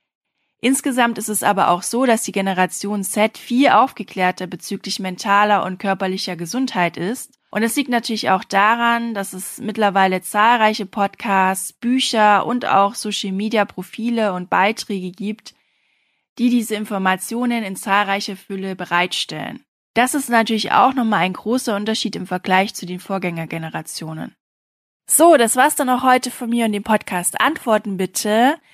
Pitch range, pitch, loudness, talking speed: 190-235 Hz, 210 Hz, -18 LUFS, 150 wpm